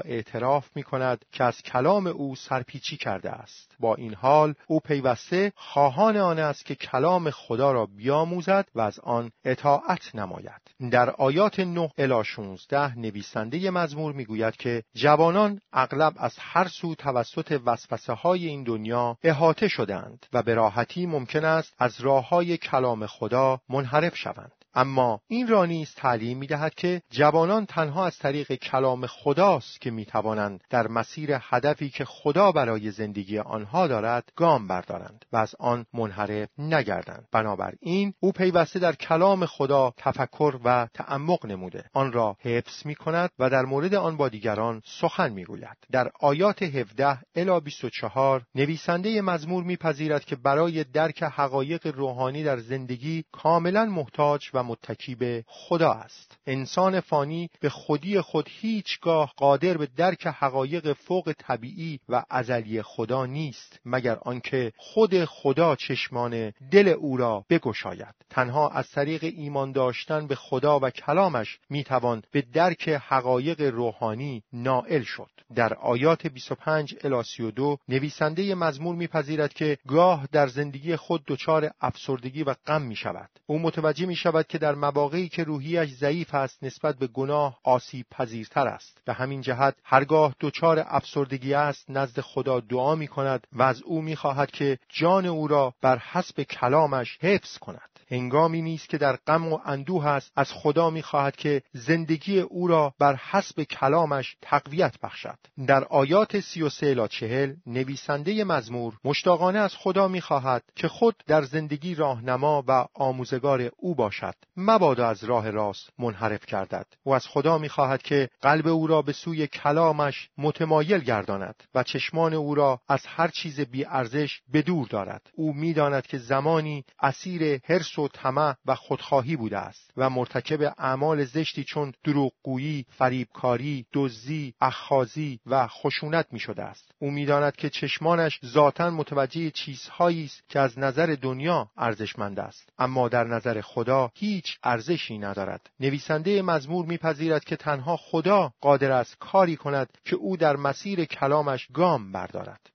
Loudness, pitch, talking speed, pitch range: -26 LUFS, 145 Hz, 145 wpm, 125-160 Hz